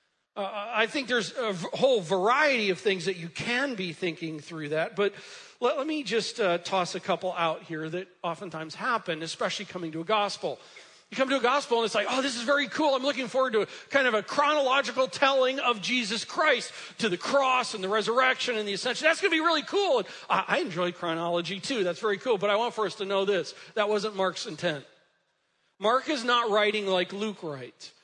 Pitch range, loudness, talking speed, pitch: 180-260 Hz, -27 LUFS, 225 wpm, 215 Hz